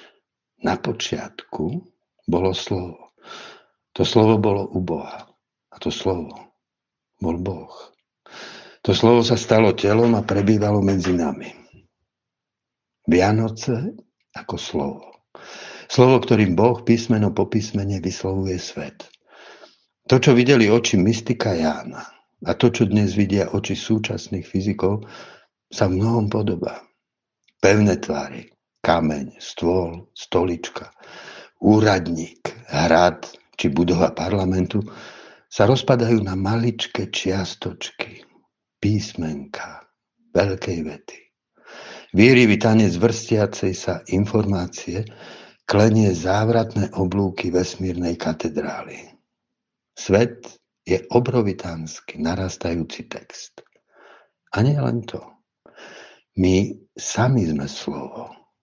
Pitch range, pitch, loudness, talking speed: 90-115 Hz, 100 Hz, -20 LUFS, 95 wpm